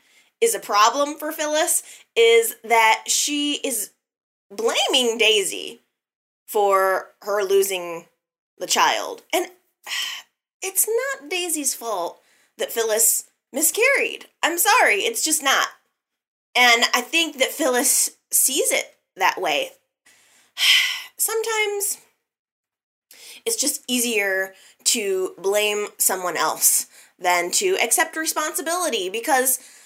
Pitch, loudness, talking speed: 310 Hz, -20 LUFS, 100 wpm